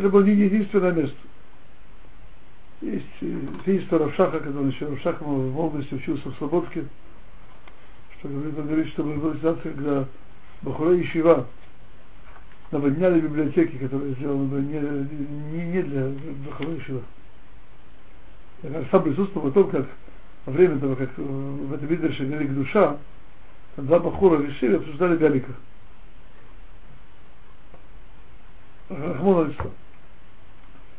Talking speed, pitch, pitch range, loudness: 110 wpm, 150 Hz, 140-165 Hz, -24 LUFS